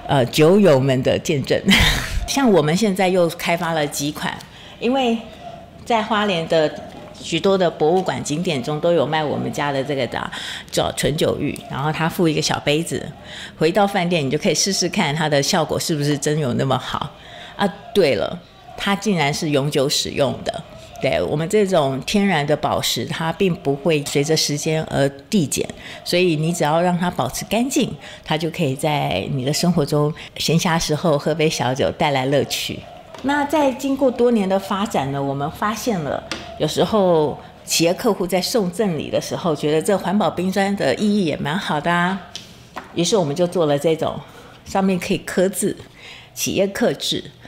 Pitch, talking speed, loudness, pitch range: 170 Hz, 265 characters per minute, -19 LUFS, 150-195 Hz